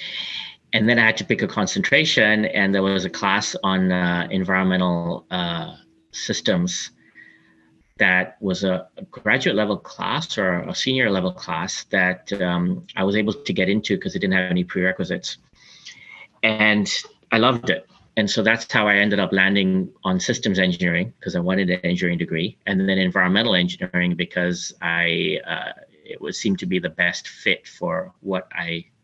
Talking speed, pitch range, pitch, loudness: 165 wpm, 90-105 Hz, 95 Hz, -21 LUFS